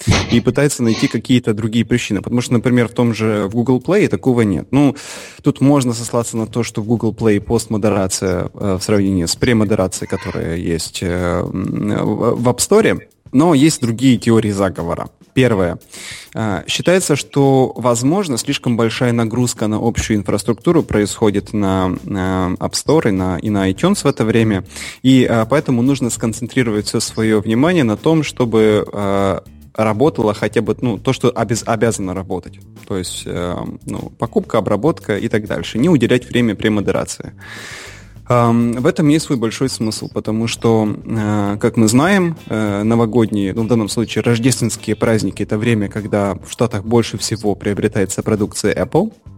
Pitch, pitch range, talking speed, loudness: 115 Hz, 100-125 Hz, 155 wpm, -16 LUFS